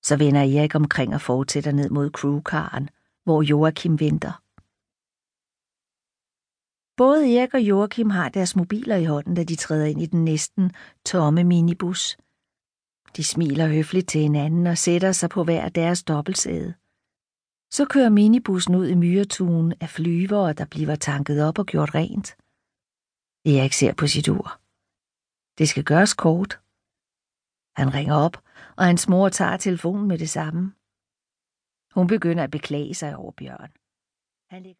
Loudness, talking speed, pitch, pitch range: -21 LUFS, 145 wpm, 165 Hz, 150-185 Hz